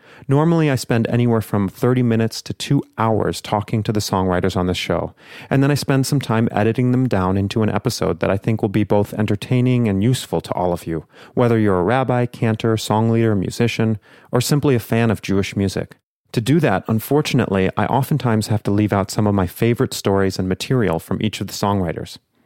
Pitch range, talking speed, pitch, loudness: 100-125 Hz, 210 wpm, 110 Hz, -19 LUFS